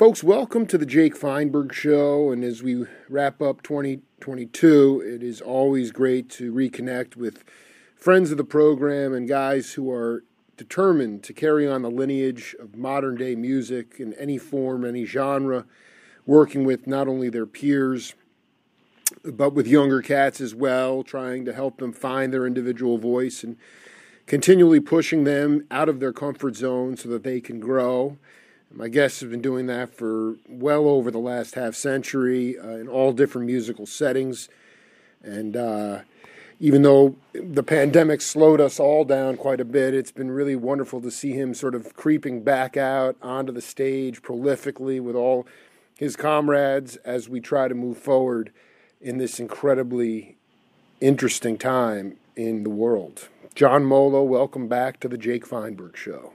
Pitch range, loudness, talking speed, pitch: 125-140 Hz, -22 LUFS, 160 wpm, 130 Hz